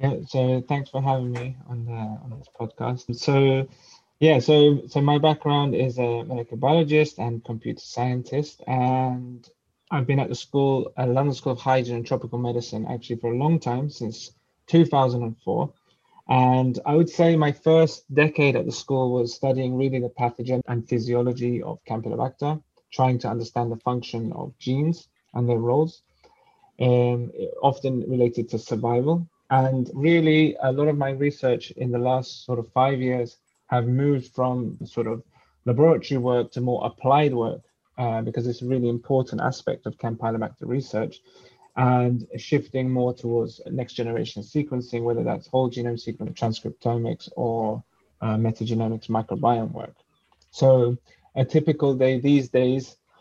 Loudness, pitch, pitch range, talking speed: -24 LUFS, 125 Hz, 120-140 Hz, 155 wpm